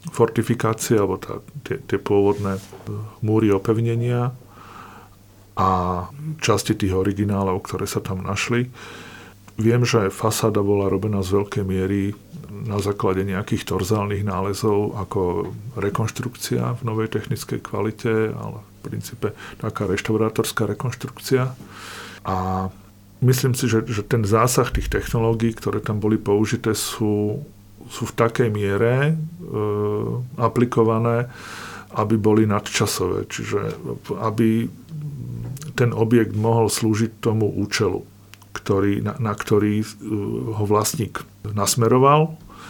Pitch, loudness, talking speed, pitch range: 110 Hz, -22 LUFS, 110 wpm, 100-115 Hz